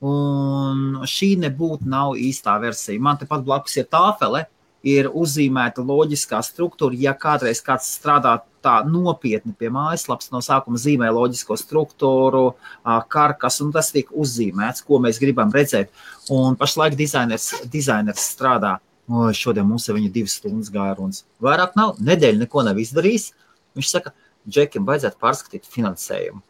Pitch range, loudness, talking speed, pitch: 125-150 Hz, -19 LUFS, 145 wpm, 140 Hz